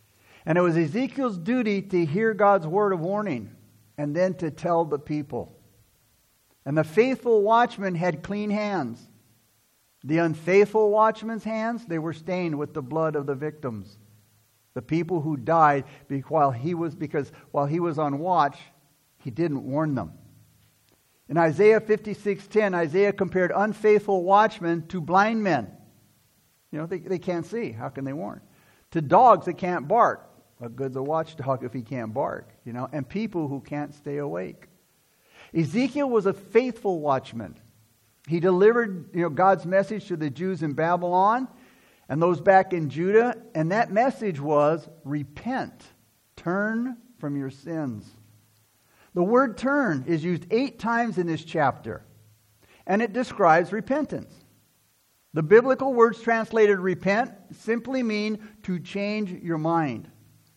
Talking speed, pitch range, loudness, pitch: 150 wpm, 145-205 Hz, -24 LUFS, 170 Hz